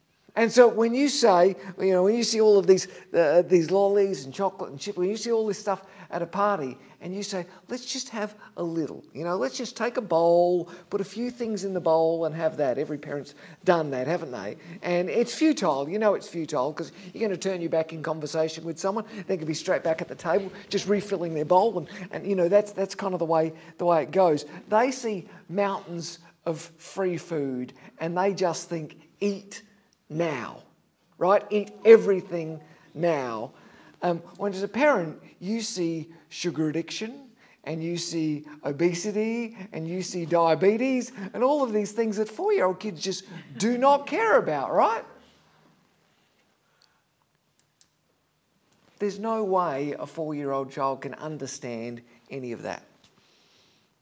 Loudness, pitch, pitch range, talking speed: -26 LUFS, 180 Hz, 160-205 Hz, 185 wpm